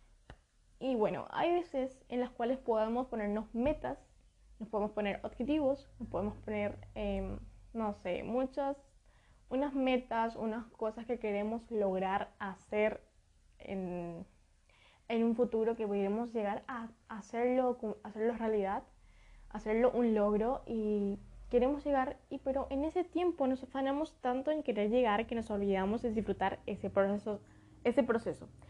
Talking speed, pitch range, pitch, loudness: 140 wpm, 205-255 Hz, 225 Hz, -35 LUFS